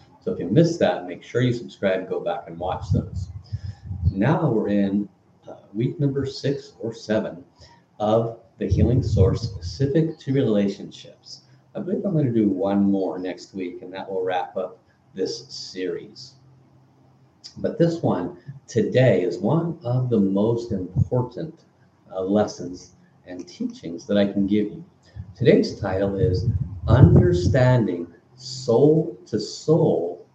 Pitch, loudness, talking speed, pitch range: 110 Hz, -22 LUFS, 145 wpm, 95-130 Hz